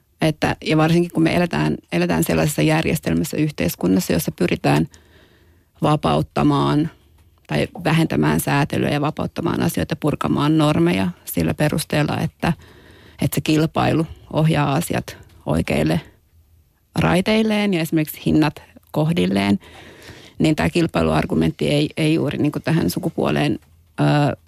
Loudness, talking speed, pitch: -20 LUFS, 115 wpm, 100 Hz